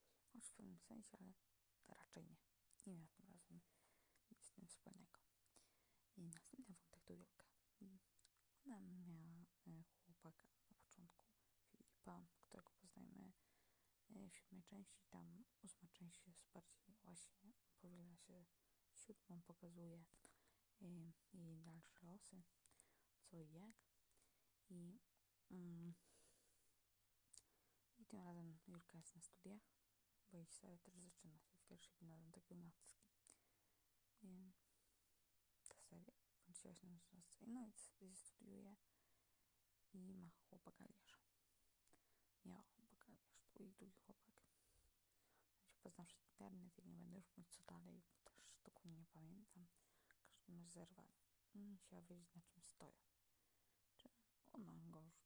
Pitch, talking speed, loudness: 170 Hz, 125 wpm, -64 LUFS